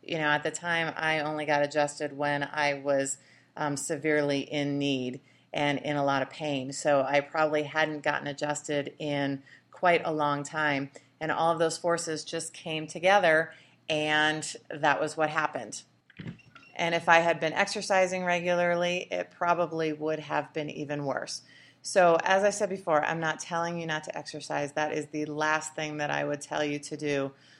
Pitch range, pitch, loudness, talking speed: 145-165 Hz, 155 Hz, -28 LUFS, 185 wpm